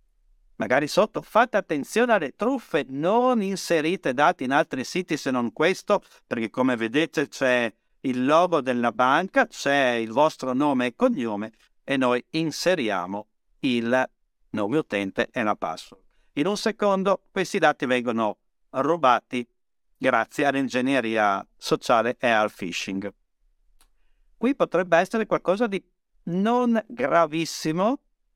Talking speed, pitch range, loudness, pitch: 125 wpm, 125-205 Hz, -24 LUFS, 160 Hz